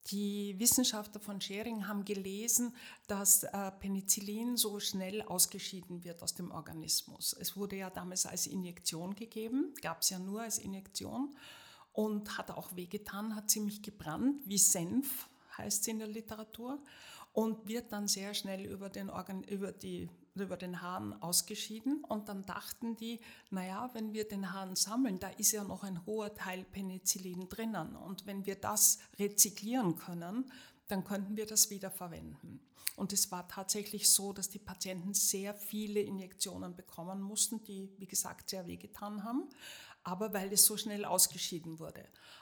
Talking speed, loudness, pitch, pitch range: 155 wpm, -35 LUFS, 200 Hz, 190-215 Hz